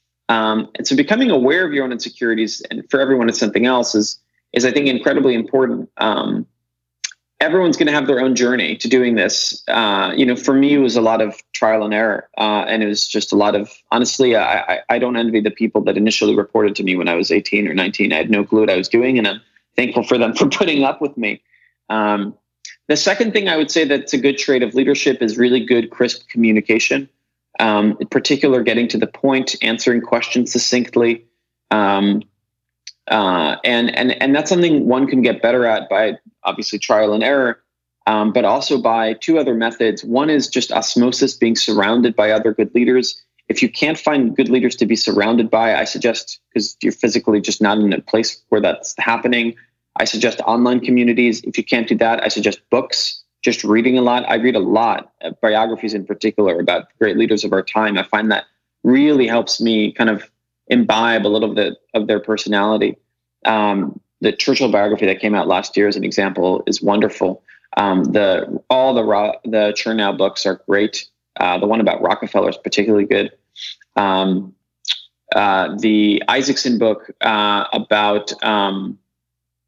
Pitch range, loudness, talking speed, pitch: 105-125 Hz, -16 LUFS, 195 wpm, 110 Hz